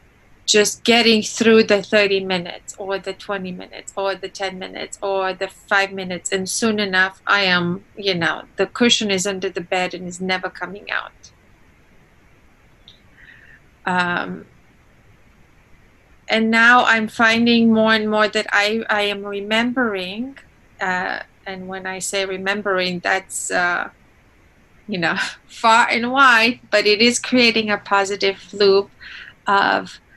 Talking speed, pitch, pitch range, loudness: 140 wpm, 200 Hz, 190-225 Hz, -18 LUFS